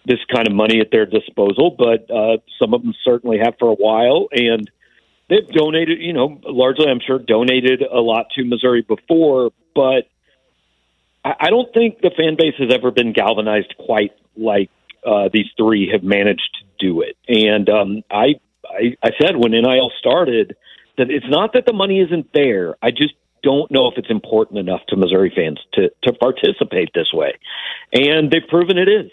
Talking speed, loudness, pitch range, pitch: 185 wpm, -16 LUFS, 110-165 Hz, 125 Hz